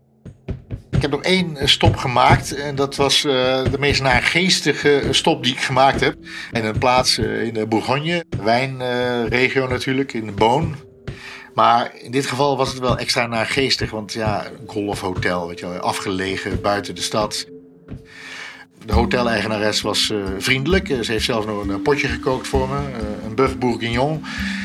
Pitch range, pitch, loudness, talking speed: 110-135 Hz, 125 Hz, -19 LUFS, 150 wpm